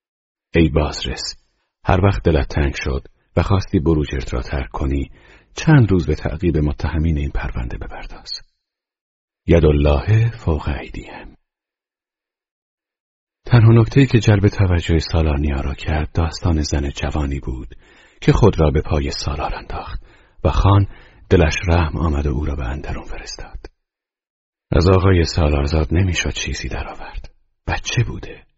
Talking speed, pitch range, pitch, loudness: 135 wpm, 75-95 Hz, 80 Hz, -18 LUFS